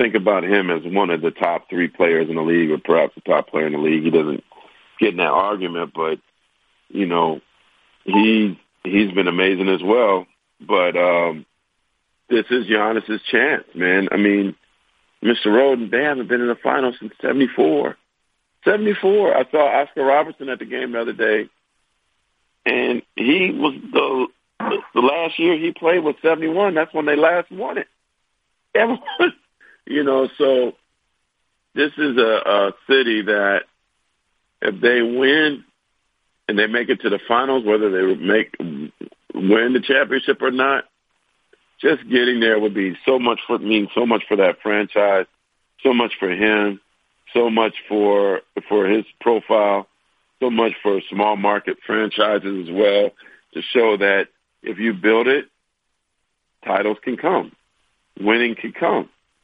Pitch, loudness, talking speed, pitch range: 110 Hz, -18 LUFS, 160 wpm, 100-130 Hz